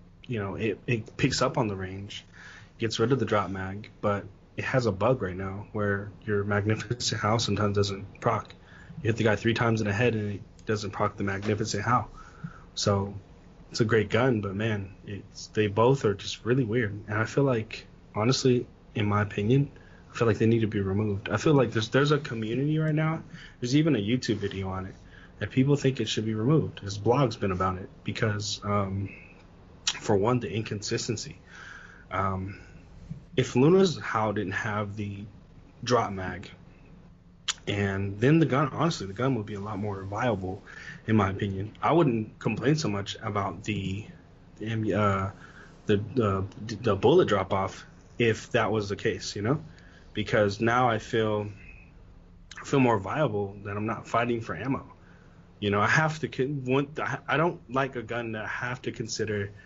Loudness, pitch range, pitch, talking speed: -28 LUFS, 100-120 Hz, 105 Hz, 185 wpm